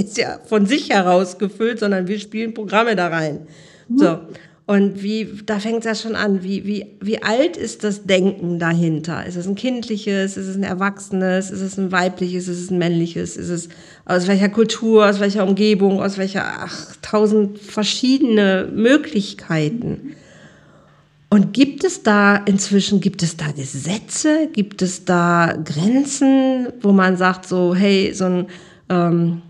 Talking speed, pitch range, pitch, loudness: 160 wpm, 180-215 Hz, 195 Hz, -18 LUFS